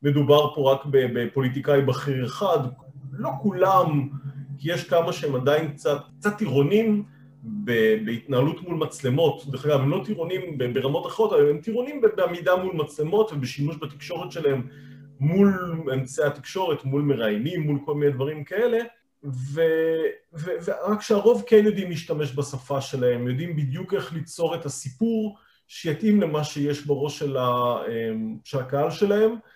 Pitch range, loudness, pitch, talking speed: 135-180 Hz, -24 LUFS, 145 Hz, 140 wpm